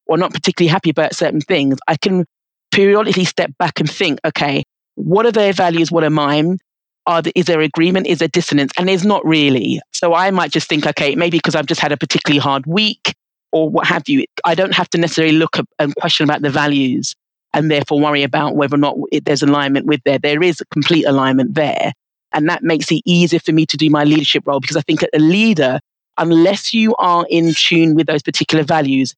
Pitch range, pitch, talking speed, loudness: 150-175 Hz, 160 Hz, 225 wpm, -14 LUFS